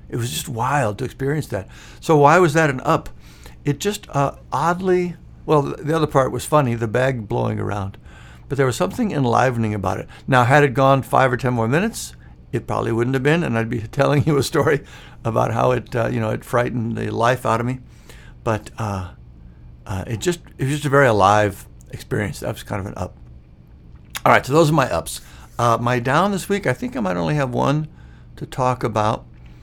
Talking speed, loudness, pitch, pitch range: 220 wpm, -20 LUFS, 125 Hz, 100-145 Hz